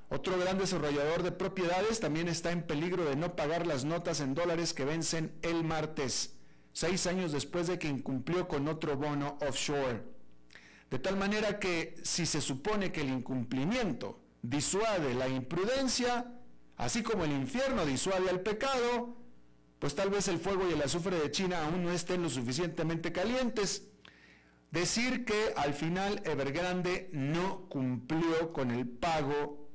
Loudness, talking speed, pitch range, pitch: -33 LUFS, 155 wpm, 145-185 Hz, 165 Hz